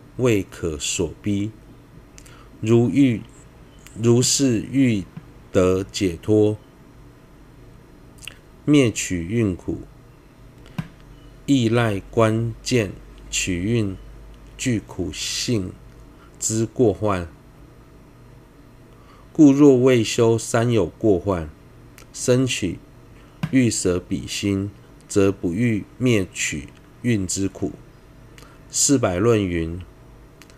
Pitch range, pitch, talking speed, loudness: 95-130 Hz, 115 Hz, 105 characters per minute, -21 LUFS